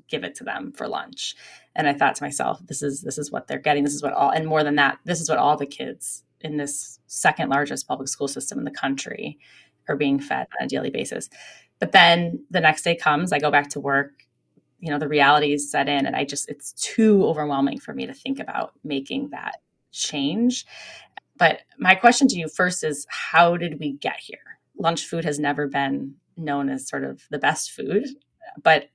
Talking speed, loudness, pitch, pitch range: 220 wpm, -22 LUFS, 150 Hz, 140-170 Hz